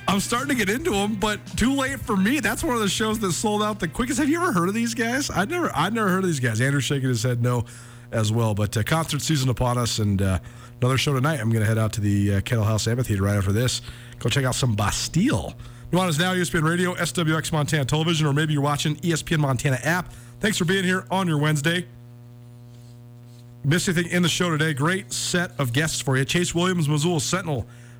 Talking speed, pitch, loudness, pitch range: 240 wpm, 150 Hz, -23 LUFS, 120-180 Hz